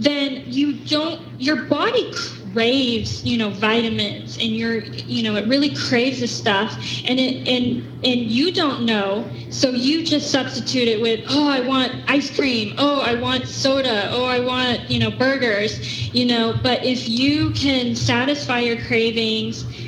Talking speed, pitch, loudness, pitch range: 165 wpm, 245 Hz, -20 LUFS, 205-270 Hz